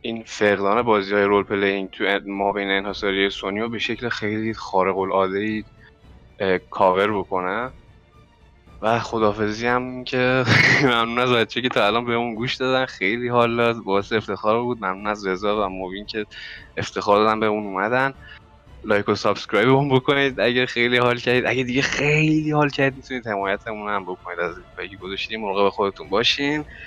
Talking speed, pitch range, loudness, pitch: 165 wpm, 100-125 Hz, -21 LUFS, 110 Hz